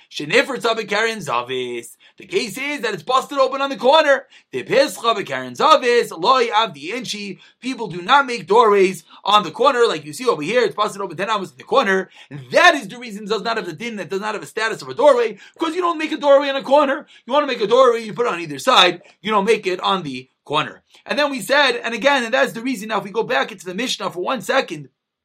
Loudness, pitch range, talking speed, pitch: -18 LUFS, 195-280 Hz, 245 wpm, 230 Hz